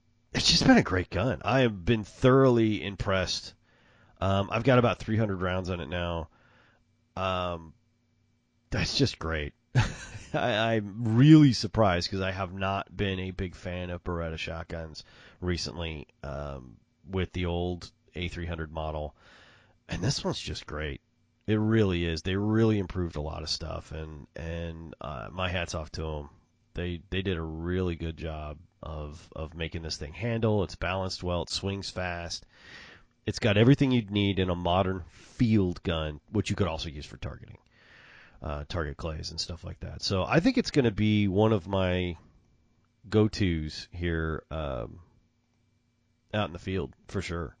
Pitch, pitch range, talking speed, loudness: 90 Hz, 80-110 Hz, 170 wpm, -29 LUFS